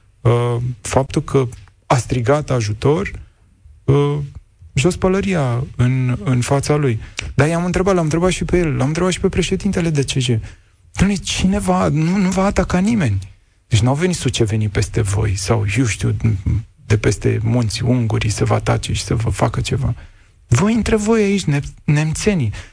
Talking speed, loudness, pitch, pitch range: 160 wpm, -18 LUFS, 125 Hz, 110-165 Hz